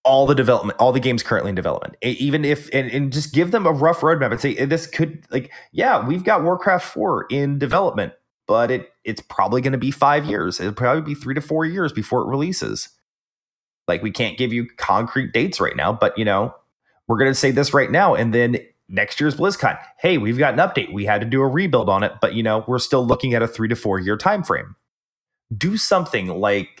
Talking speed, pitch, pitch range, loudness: 230 wpm, 135 Hz, 120-155 Hz, -19 LUFS